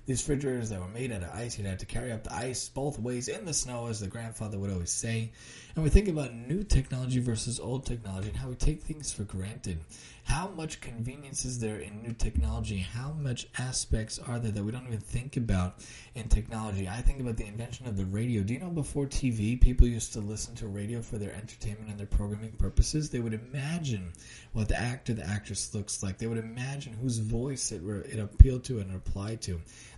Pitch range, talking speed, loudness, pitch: 105-125 Hz, 225 wpm, -33 LUFS, 115 Hz